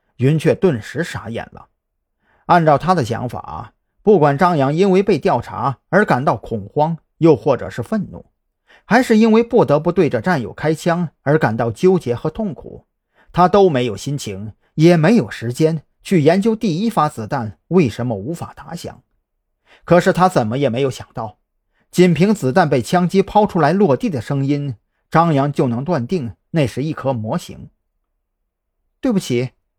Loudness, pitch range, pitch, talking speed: -16 LUFS, 120-180 Hz, 150 Hz, 240 characters per minute